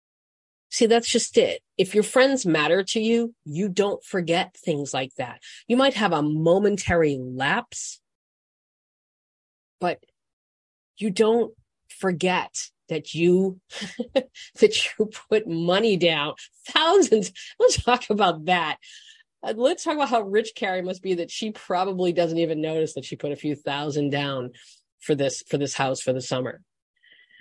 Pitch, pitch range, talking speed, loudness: 190 Hz, 160-235 Hz, 145 wpm, -23 LUFS